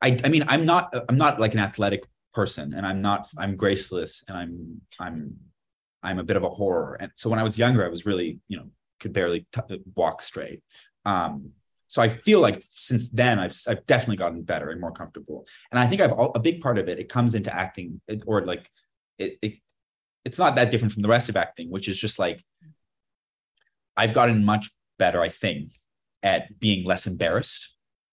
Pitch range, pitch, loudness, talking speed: 95-120 Hz, 110 Hz, -24 LUFS, 210 wpm